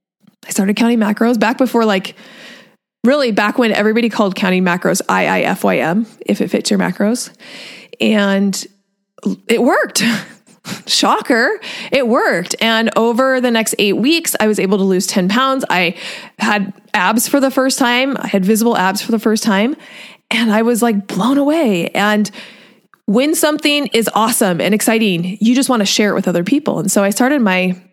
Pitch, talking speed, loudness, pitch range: 225 Hz, 175 wpm, -14 LUFS, 200-250 Hz